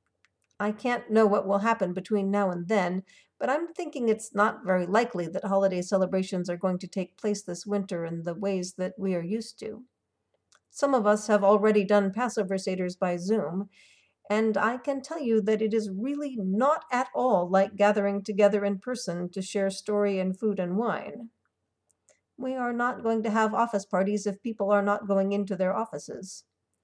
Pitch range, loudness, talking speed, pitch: 190-220 Hz, -27 LUFS, 190 wpm, 205 Hz